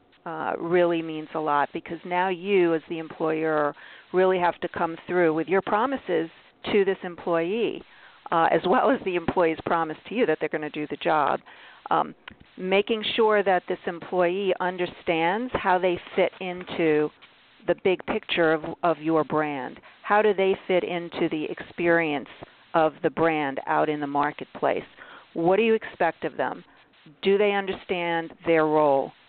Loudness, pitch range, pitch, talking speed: -25 LUFS, 160-190 Hz, 170 Hz, 165 wpm